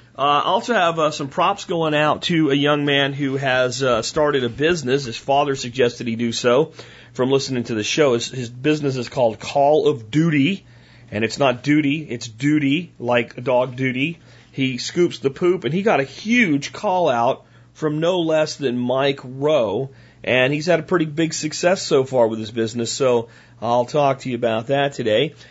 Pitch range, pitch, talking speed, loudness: 120-150 Hz, 135 Hz, 200 wpm, -20 LUFS